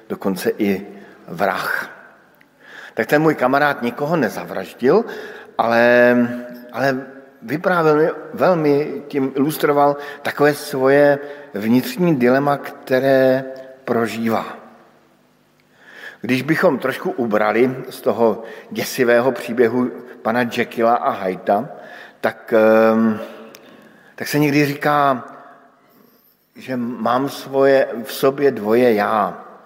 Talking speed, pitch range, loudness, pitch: 90 wpm, 120-145 Hz, -18 LUFS, 135 Hz